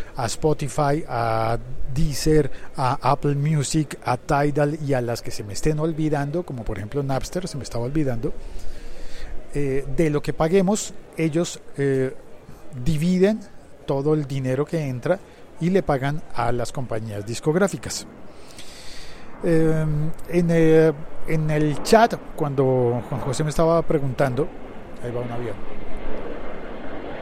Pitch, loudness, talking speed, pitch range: 145 Hz, -23 LUFS, 135 wpm, 130-160 Hz